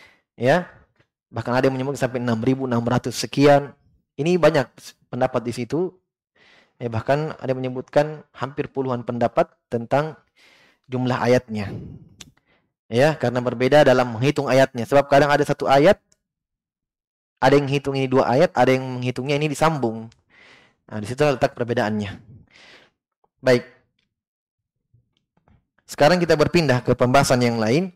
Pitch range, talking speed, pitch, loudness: 120-145 Hz, 130 wpm, 130 Hz, -20 LUFS